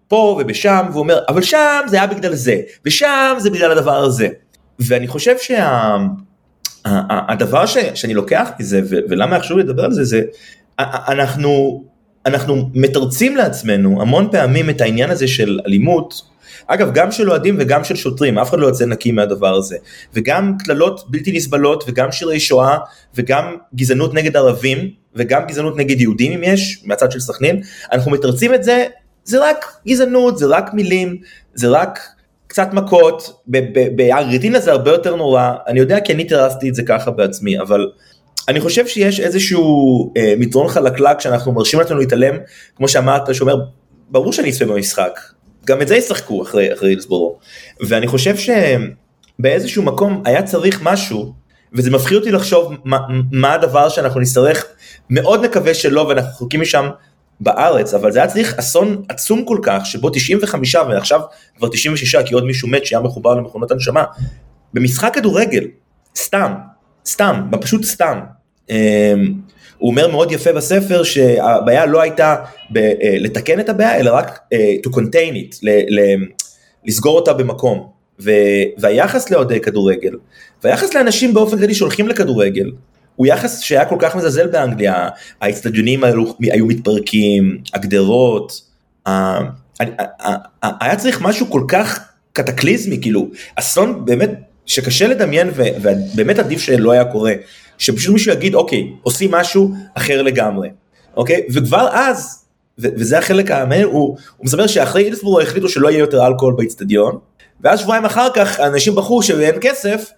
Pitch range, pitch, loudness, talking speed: 125-195 Hz, 145 Hz, -14 LUFS, 155 wpm